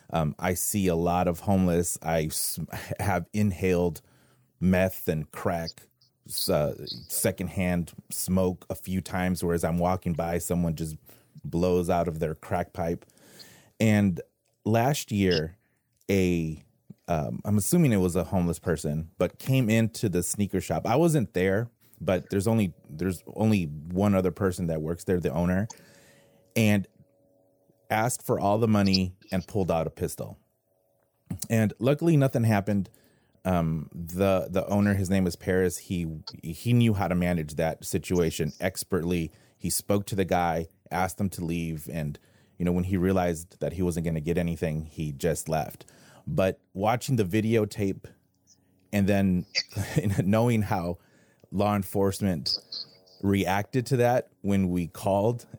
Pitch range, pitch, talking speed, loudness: 90-105 Hz, 95 Hz, 150 wpm, -27 LUFS